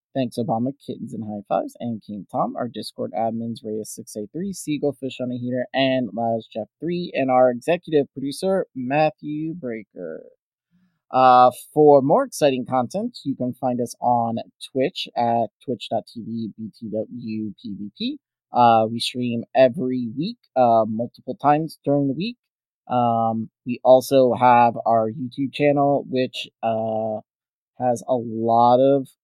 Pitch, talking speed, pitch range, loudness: 125 Hz, 130 wpm, 115-140 Hz, -21 LUFS